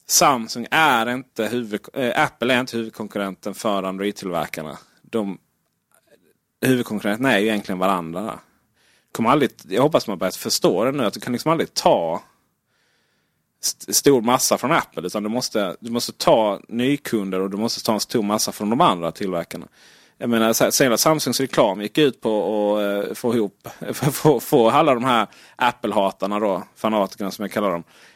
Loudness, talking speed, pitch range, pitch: -21 LUFS, 165 wpm, 100-125 Hz, 110 Hz